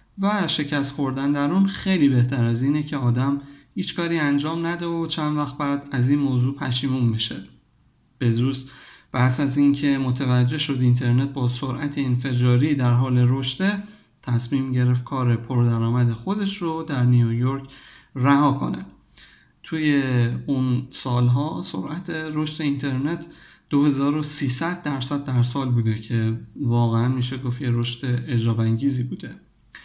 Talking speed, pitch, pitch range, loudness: 135 wpm, 135 Hz, 125-145 Hz, -22 LUFS